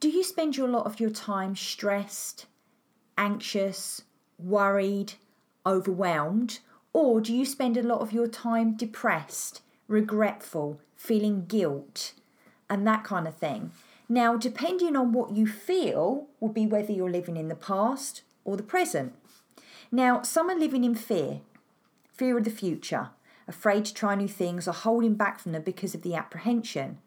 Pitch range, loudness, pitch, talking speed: 195-240 Hz, -28 LUFS, 220 Hz, 155 wpm